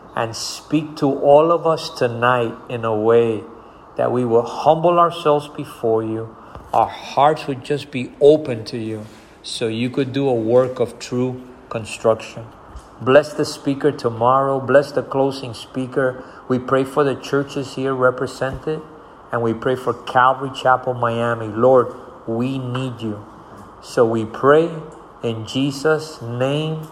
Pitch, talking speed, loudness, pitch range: 130 Hz, 145 wpm, -19 LUFS, 115-145 Hz